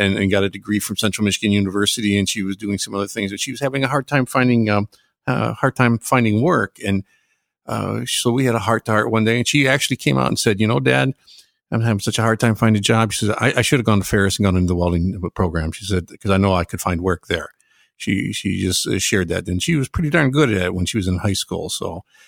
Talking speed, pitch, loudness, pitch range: 285 wpm, 105 Hz, -19 LUFS, 100-120 Hz